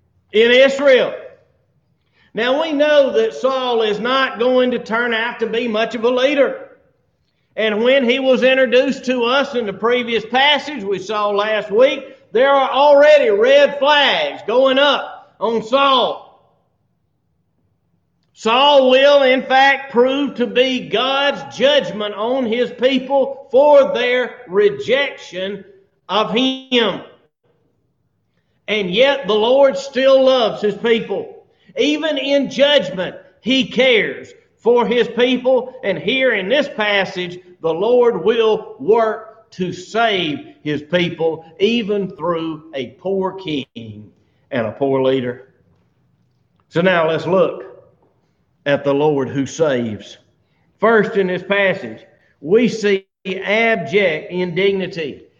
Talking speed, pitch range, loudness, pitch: 125 wpm, 195-275 Hz, -16 LUFS, 240 Hz